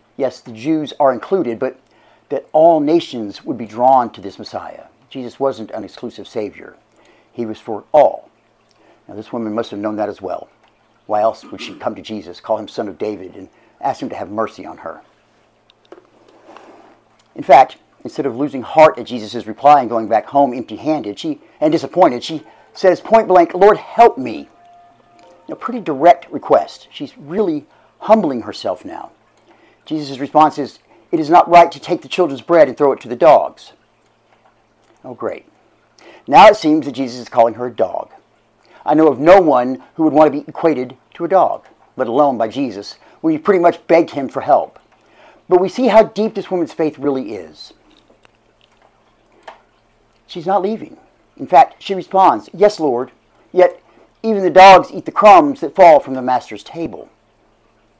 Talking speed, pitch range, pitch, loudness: 180 wpm, 125-185 Hz, 155 Hz, -14 LUFS